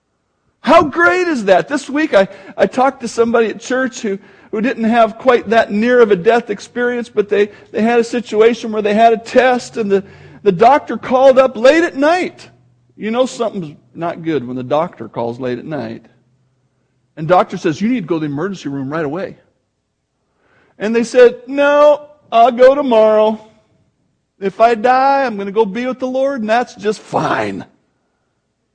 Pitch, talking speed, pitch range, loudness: 230 Hz, 190 wpm, 195-255 Hz, -14 LUFS